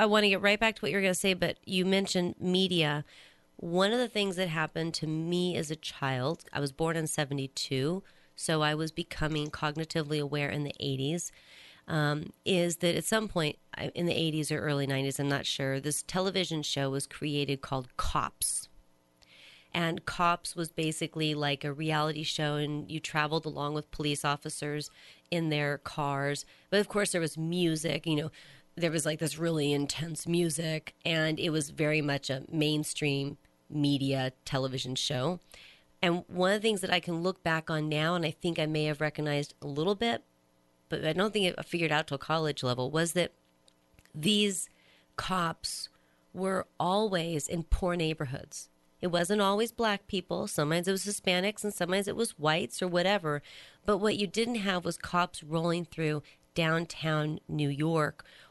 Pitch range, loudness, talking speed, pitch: 145-175 Hz, -31 LUFS, 180 wpm, 155 Hz